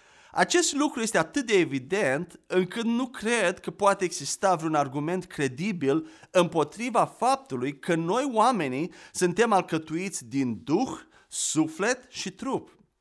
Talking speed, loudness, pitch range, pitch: 125 wpm, -27 LUFS, 155-230 Hz, 185 Hz